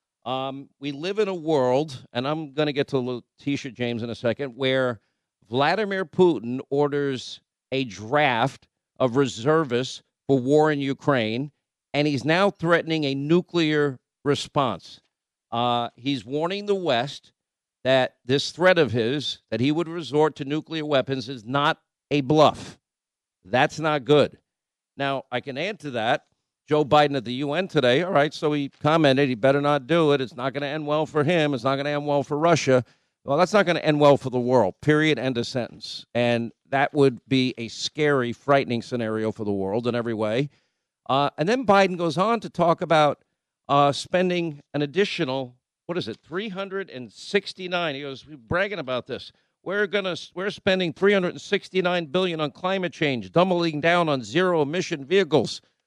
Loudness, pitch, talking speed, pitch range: -23 LUFS, 145 Hz, 185 wpm, 130-165 Hz